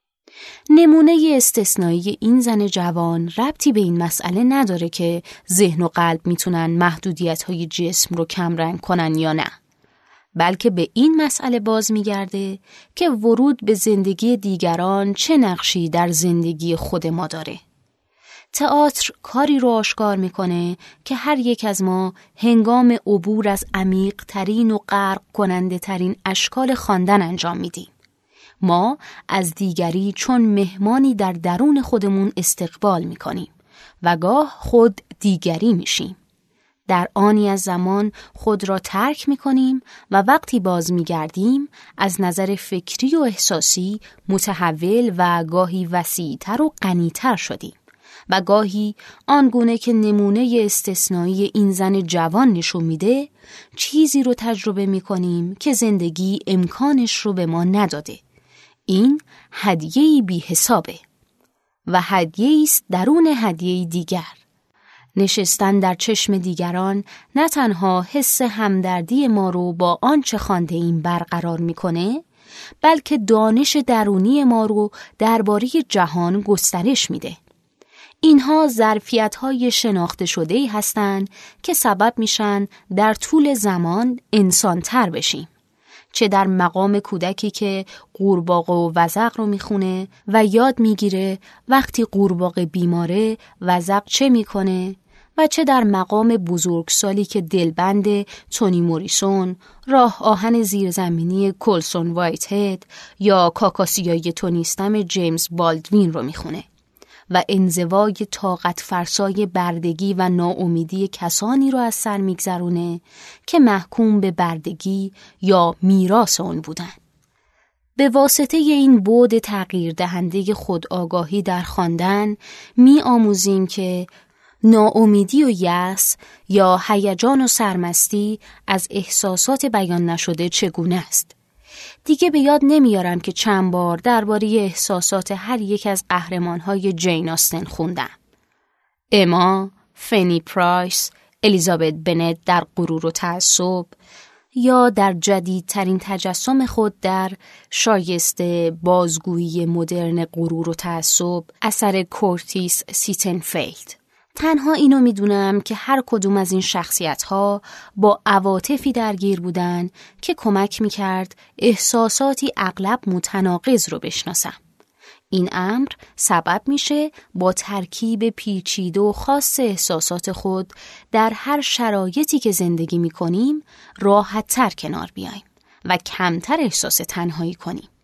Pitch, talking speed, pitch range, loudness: 195 Hz, 120 wpm, 180-225 Hz, -18 LUFS